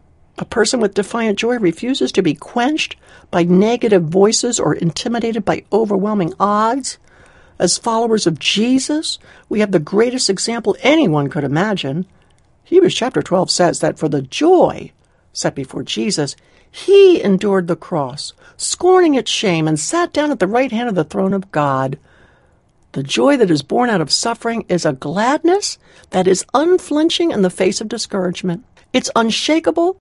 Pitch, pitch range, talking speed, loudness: 210 Hz, 175-250 Hz, 160 wpm, -16 LUFS